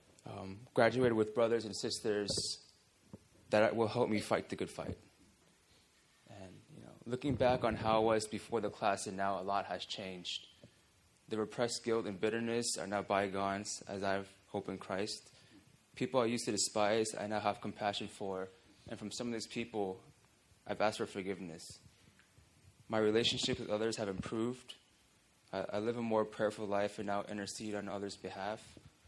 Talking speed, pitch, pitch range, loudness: 175 wpm, 105 Hz, 100-115 Hz, -37 LUFS